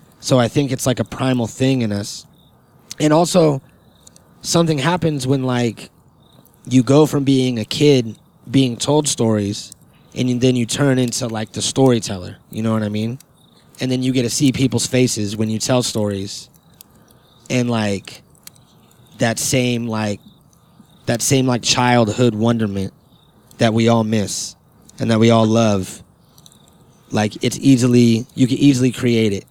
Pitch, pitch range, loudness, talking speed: 120 Hz, 110-135 Hz, -17 LUFS, 155 wpm